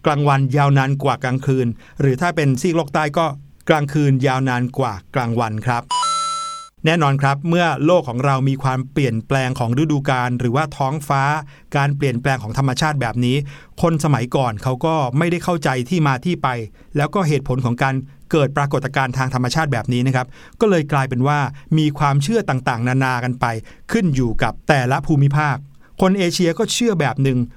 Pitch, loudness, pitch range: 140 Hz, -18 LUFS, 130-155 Hz